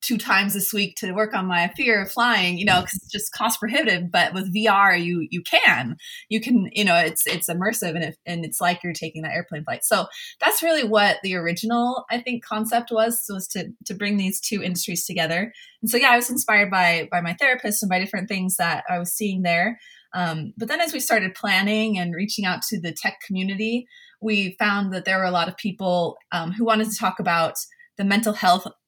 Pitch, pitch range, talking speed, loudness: 200 Hz, 180-220 Hz, 230 wpm, -21 LUFS